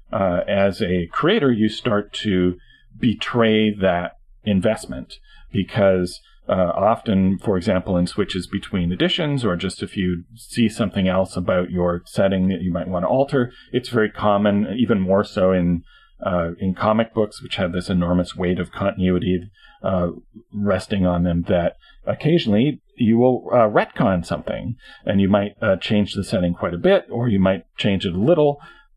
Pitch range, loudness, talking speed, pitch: 90-110 Hz, -20 LUFS, 170 wpm, 95 Hz